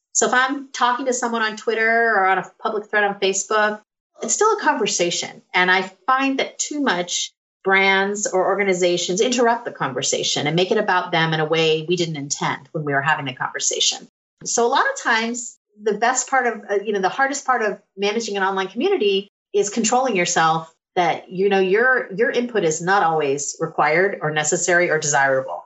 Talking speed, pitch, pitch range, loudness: 195 wpm, 200 Hz, 175-240 Hz, -19 LUFS